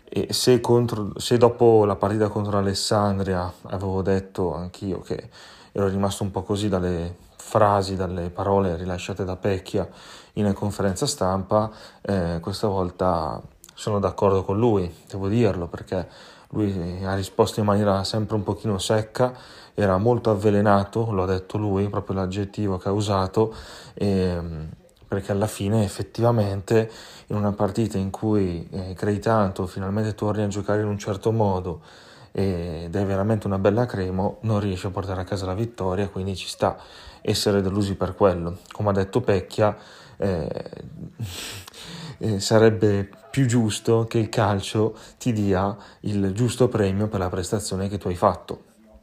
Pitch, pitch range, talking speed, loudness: 100 Hz, 95-110 Hz, 155 wpm, -24 LUFS